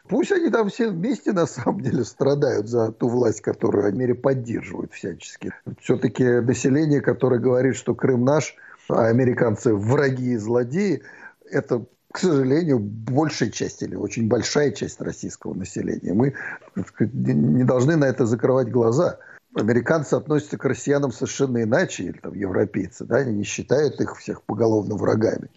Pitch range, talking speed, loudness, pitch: 120-140 Hz, 150 wpm, -22 LUFS, 130 Hz